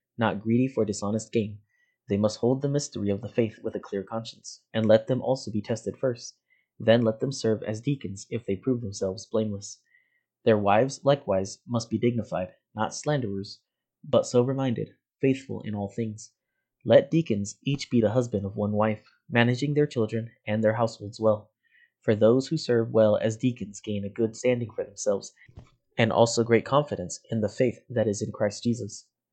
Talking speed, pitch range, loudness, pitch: 185 wpm, 105-125 Hz, -27 LUFS, 110 Hz